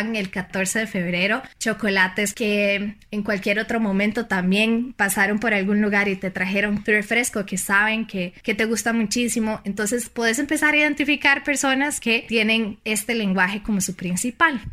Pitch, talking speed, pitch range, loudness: 215 Hz, 165 wpm, 200-230 Hz, -21 LUFS